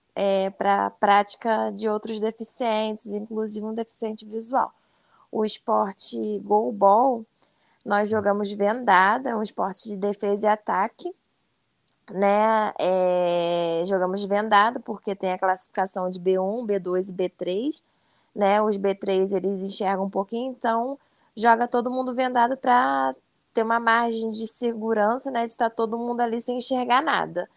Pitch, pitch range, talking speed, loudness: 215 Hz, 195-230 Hz, 140 wpm, -24 LUFS